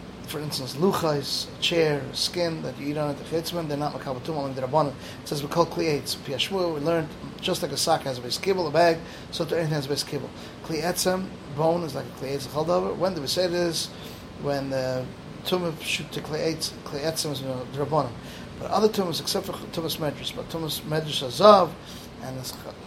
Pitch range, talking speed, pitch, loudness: 145-170 Hz, 215 wpm, 155 Hz, -26 LUFS